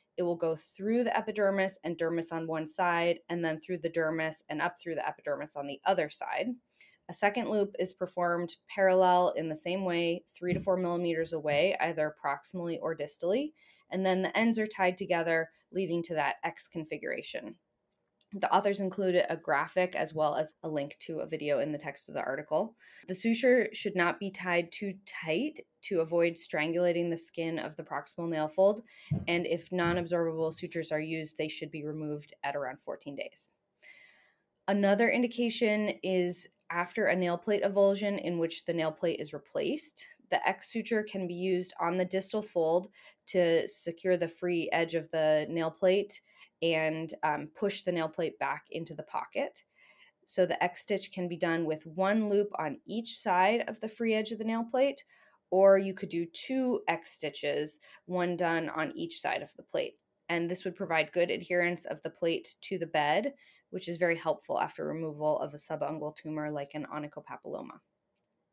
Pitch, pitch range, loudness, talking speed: 175 Hz, 160-195 Hz, -32 LUFS, 185 wpm